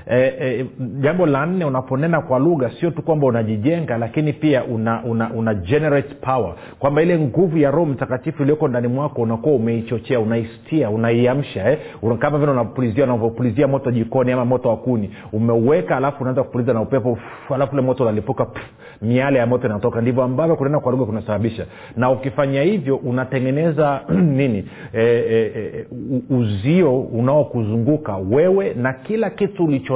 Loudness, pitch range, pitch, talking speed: -19 LUFS, 115-145 Hz, 130 Hz, 145 wpm